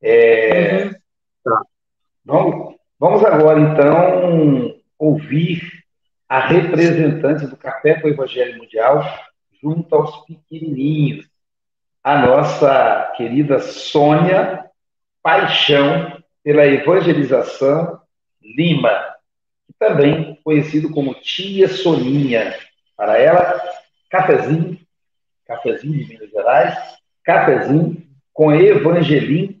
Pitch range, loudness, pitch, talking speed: 145-175 Hz, -15 LUFS, 155 Hz, 80 wpm